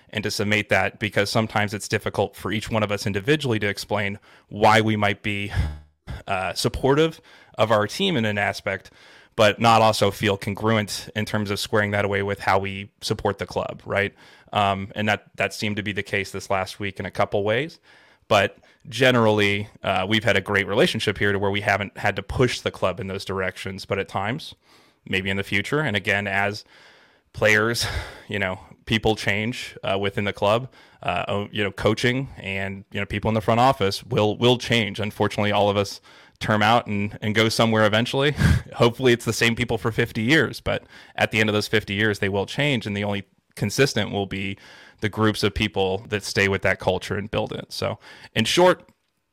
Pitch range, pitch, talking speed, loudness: 100-110 Hz, 105 Hz, 205 wpm, -22 LUFS